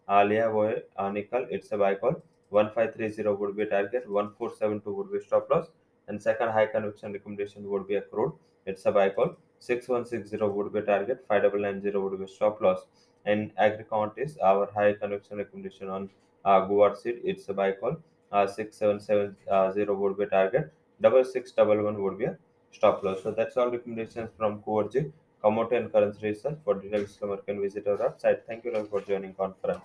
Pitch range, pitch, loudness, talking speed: 100-115 Hz, 105 Hz, -28 LUFS, 190 wpm